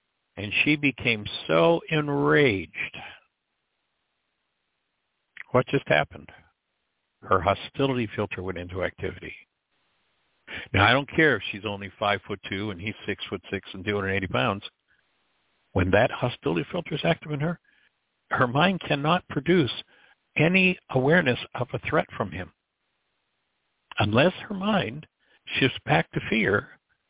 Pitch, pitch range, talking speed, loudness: 125 Hz, 100-155 Hz, 135 wpm, -25 LUFS